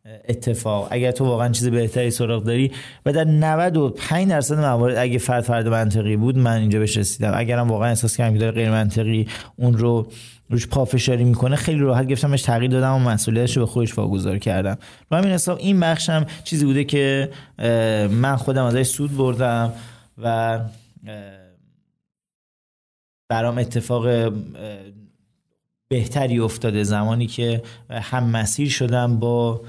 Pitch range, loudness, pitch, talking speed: 115-130 Hz, -20 LUFS, 120 Hz, 150 wpm